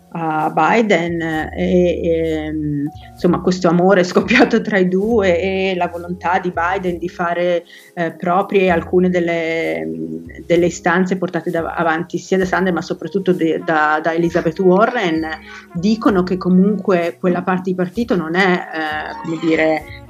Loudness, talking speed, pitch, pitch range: -17 LUFS, 145 wpm, 175 Hz, 165-185 Hz